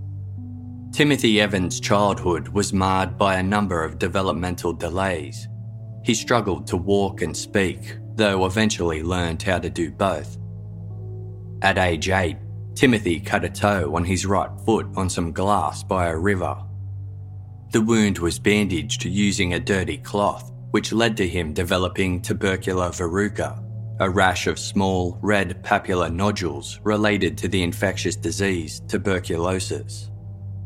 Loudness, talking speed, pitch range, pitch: -22 LUFS, 135 wpm, 95-105 Hz, 100 Hz